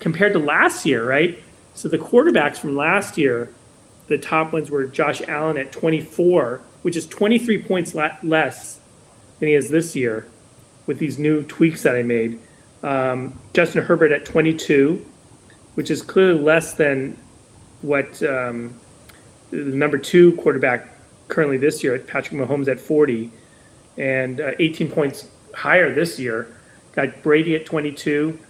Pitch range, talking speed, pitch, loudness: 130-160 Hz, 145 wpm, 150 Hz, -19 LUFS